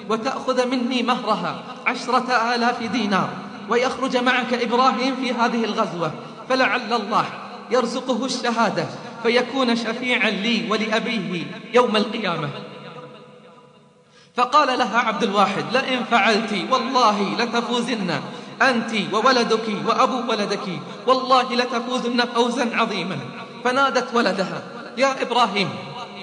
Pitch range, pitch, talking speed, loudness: 220-250 Hz, 235 Hz, 95 wpm, -21 LUFS